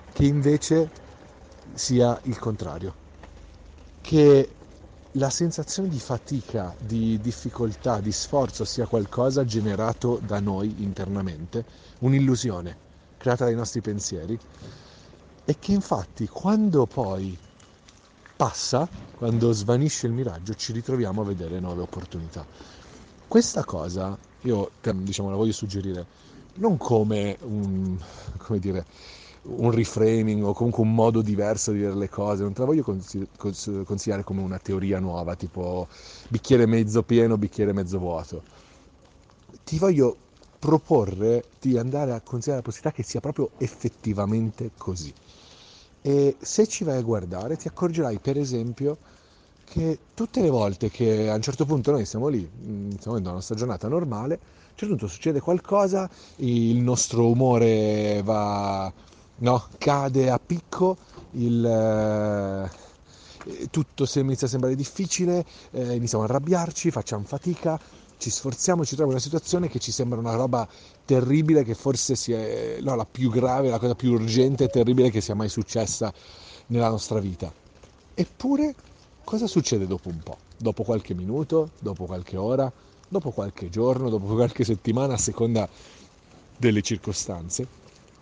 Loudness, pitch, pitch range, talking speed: -25 LUFS, 115 Hz, 100-135 Hz, 135 wpm